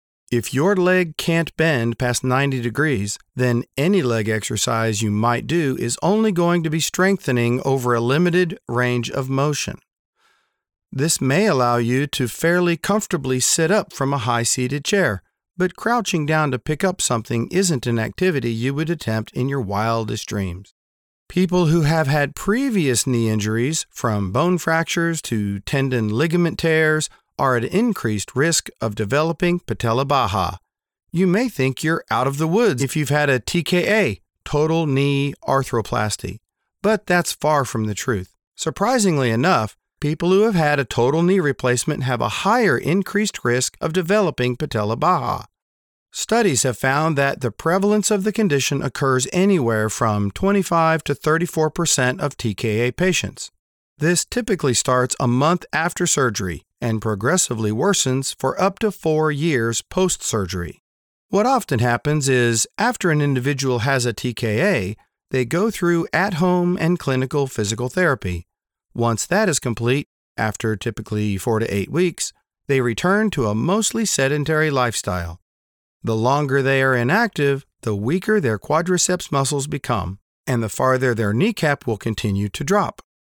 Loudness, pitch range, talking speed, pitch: -20 LUFS, 115-175 Hz, 155 wpm, 135 Hz